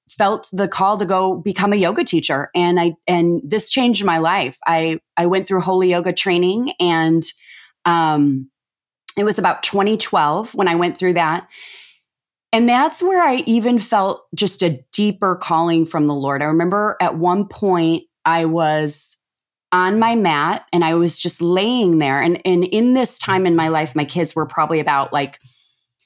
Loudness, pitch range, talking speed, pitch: -17 LUFS, 160-200 Hz, 175 wpm, 175 Hz